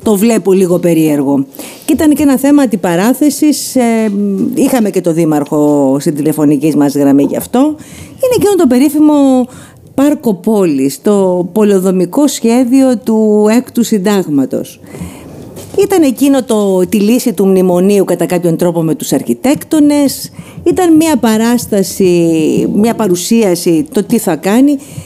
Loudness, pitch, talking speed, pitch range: -10 LUFS, 215 Hz, 130 wpm, 175-270 Hz